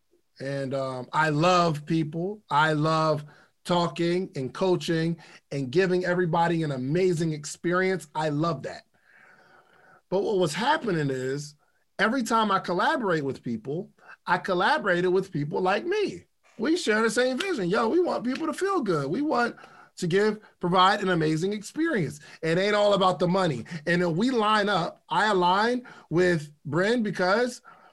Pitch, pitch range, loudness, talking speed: 180 Hz, 160-215 Hz, -26 LUFS, 155 wpm